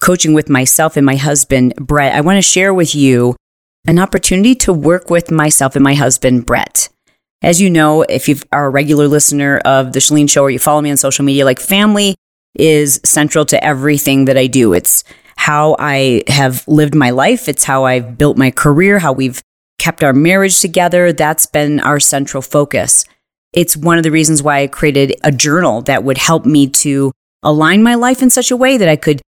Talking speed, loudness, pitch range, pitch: 205 wpm, -10 LUFS, 135-165 Hz, 150 Hz